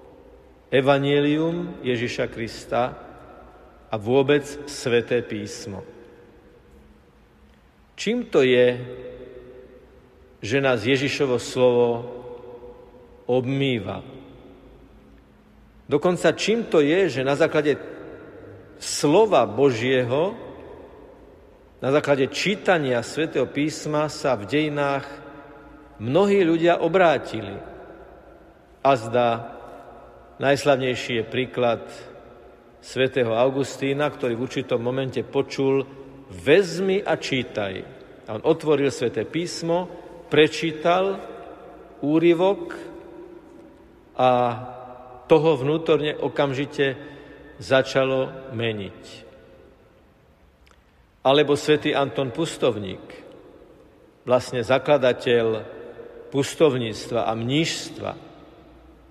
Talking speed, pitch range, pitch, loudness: 75 wpm, 120-150 Hz, 135 Hz, -22 LUFS